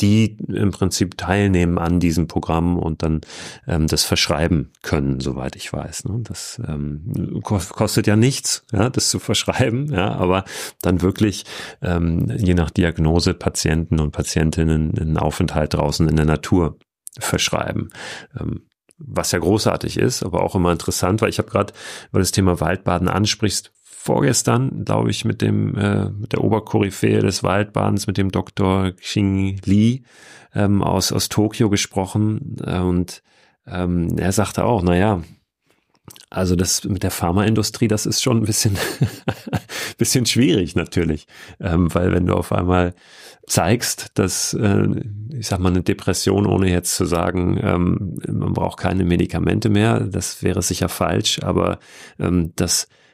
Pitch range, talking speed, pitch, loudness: 85-105 Hz, 150 wpm, 95 Hz, -19 LUFS